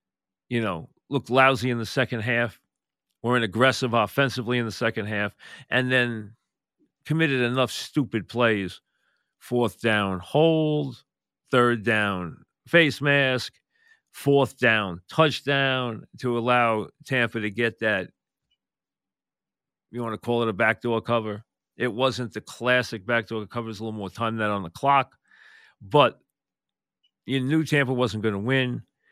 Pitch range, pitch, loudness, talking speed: 110-130 Hz, 120 Hz, -24 LUFS, 140 wpm